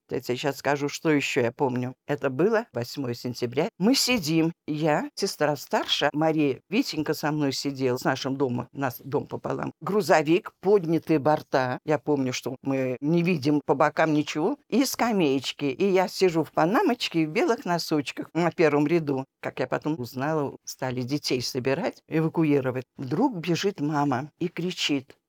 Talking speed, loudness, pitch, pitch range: 160 wpm, -26 LUFS, 150 Hz, 135-170 Hz